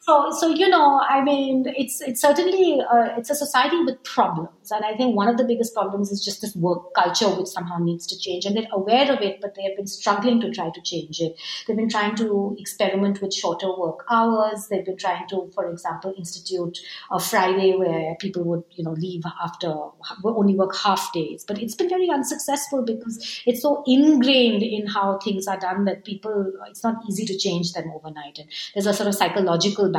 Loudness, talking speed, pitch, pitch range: -22 LUFS, 210 wpm, 200 Hz, 185-235 Hz